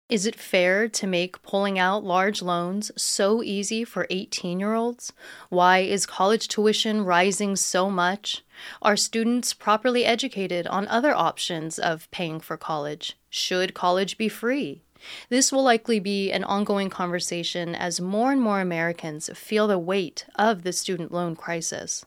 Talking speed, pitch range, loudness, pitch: 155 wpm, 180-220 Hz, -24 LUFS, 195 Hz